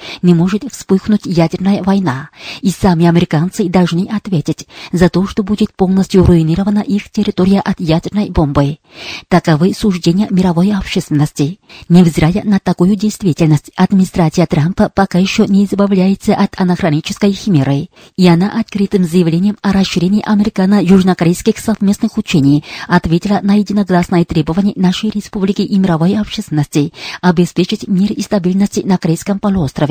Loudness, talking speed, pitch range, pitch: -13 LUFS, 125 wpm, 170-205 Hz, 190 Hz